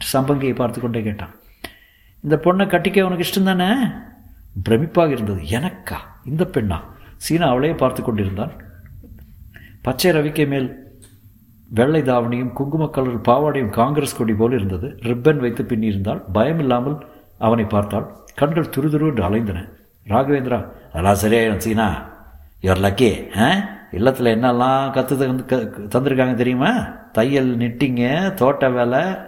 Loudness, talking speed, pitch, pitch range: -19 LUFS, 125 wpm, 120 Hz, 105-140 Hz